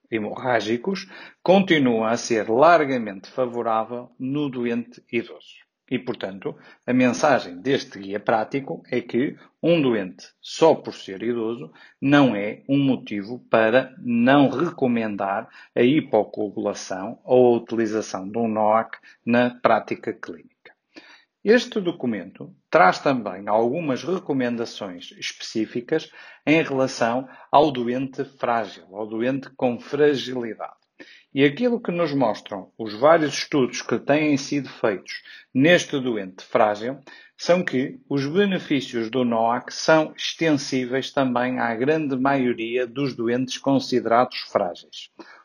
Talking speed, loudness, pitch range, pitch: 120 wpm, -22 LUFS, 115-145 Hz, 125 Hz